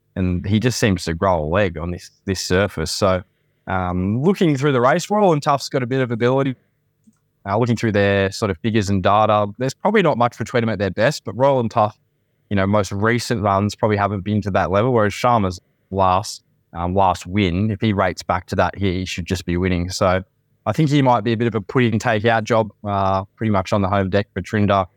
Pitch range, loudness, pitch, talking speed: 95-120 Hz, -19 LUFS, 105 Hz, 245 wpm